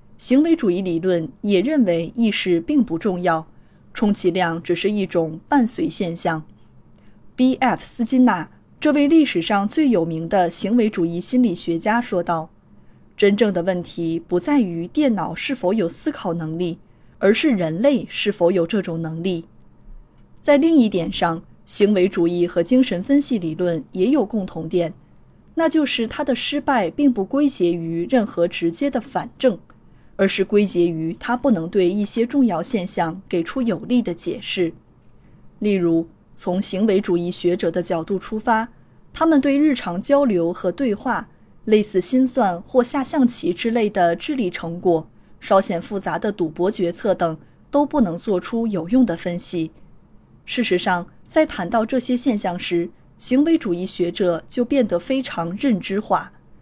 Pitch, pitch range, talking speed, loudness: 195 Hz, 170-250 Hz, 235 characters per minute, -20 LUFS